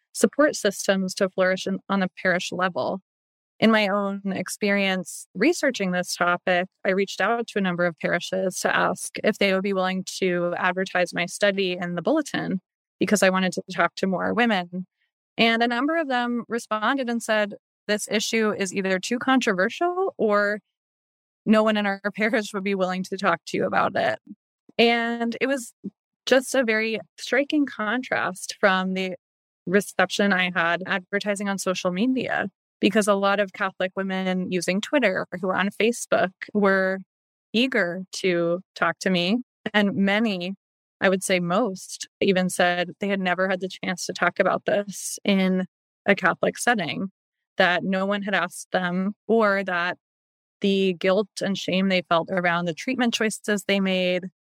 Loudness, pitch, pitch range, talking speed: -23 LUFS, 195 Hz, 185-215 Hz, 170 wpm